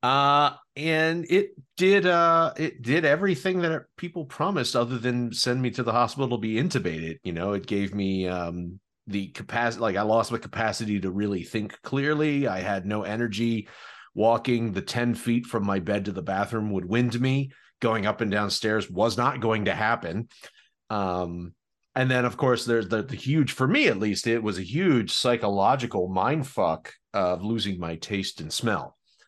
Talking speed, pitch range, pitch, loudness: 185 wpm, 100-130 Hz, 115 Hz, -26 LUFS